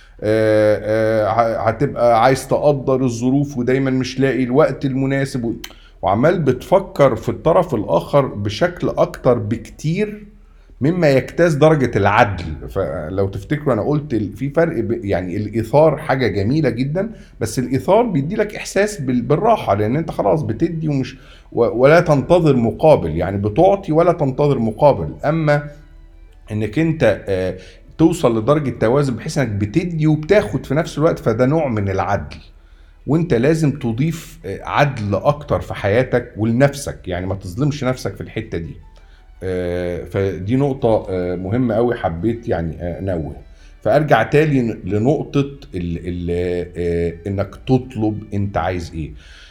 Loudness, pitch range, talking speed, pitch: -18 LUFS, 100-145 Hz, 130 wpm, 120 Hz